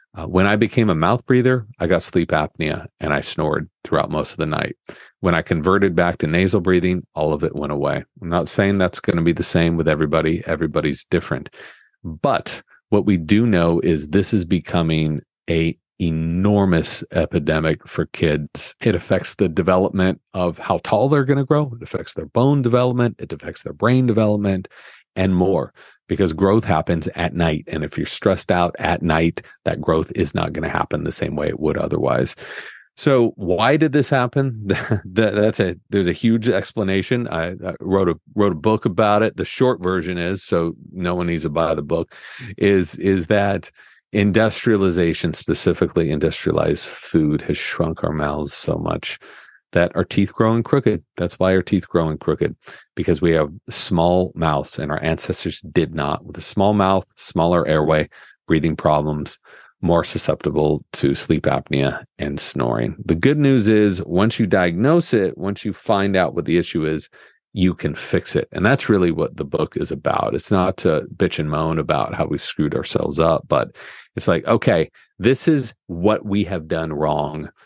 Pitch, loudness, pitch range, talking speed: 95 Hz, -19 LUFS, 80-110 Hz, 185 wpm